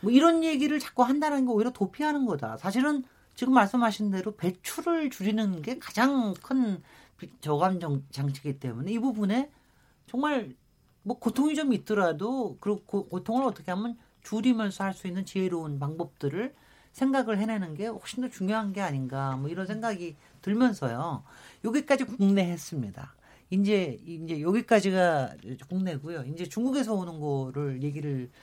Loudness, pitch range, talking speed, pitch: -29 LUFS, 165-245 Hz, 325 characters per minute, 200 Hz